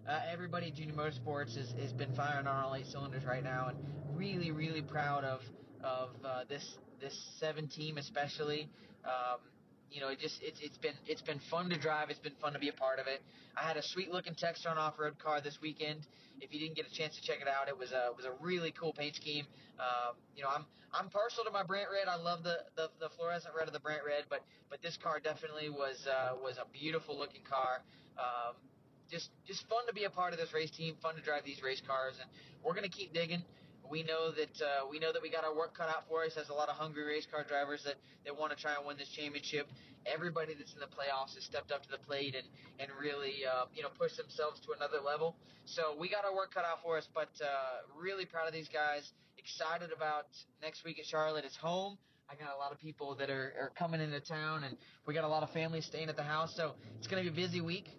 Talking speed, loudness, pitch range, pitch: 250 wpm, -40 LUFS, 140-160 Hz, 150 Hz